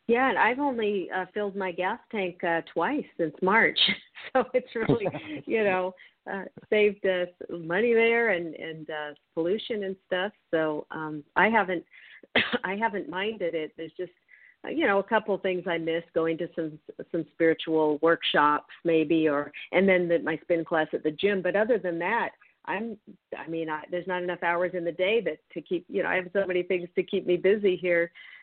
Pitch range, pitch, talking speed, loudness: 165-200 Hz, 180 Hz, 200 wpm, -27 LUFS